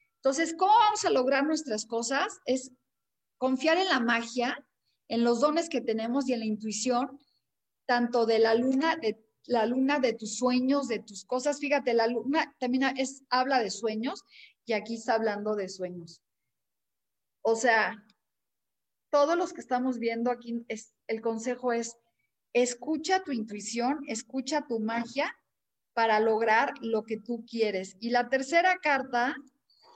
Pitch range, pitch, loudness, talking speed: 225-275 Hz, 245 Hz, -28 LUFS, 150 wpm